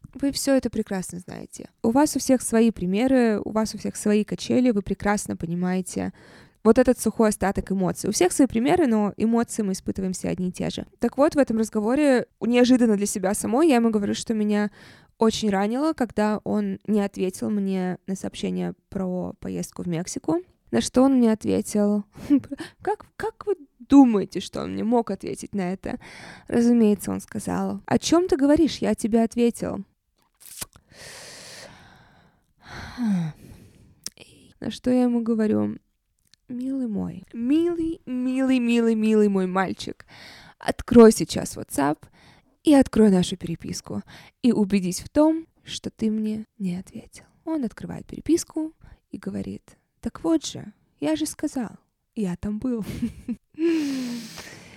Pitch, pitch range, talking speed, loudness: 220 Hz, 195-260 Hz, 145 wpm, -23 LUFS